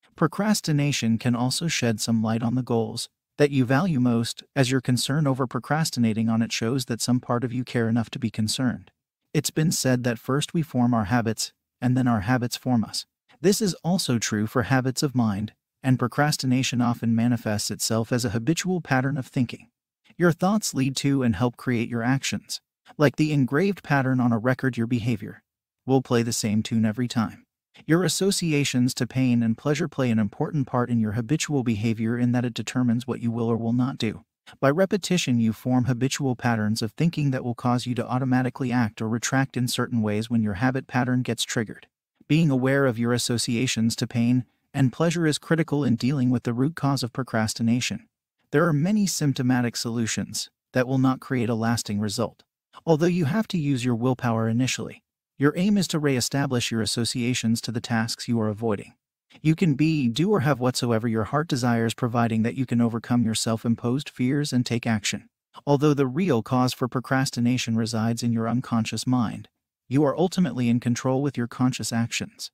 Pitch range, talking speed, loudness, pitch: 115-140 Hz, 195 wpm, -24 LUFS, 125 Hz